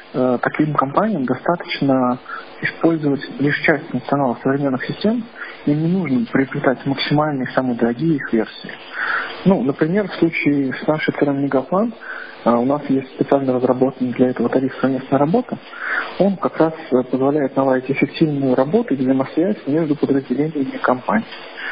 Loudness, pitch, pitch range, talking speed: -19 LUFS, 140 Hz, 130-160 Hz, 135 wpm